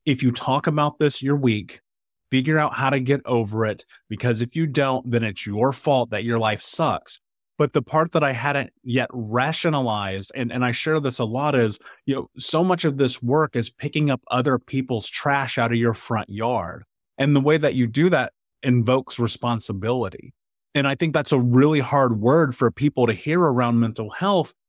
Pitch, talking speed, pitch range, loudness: 130 Hz, 205 wpm, 120-145 Hz, -22 LUFS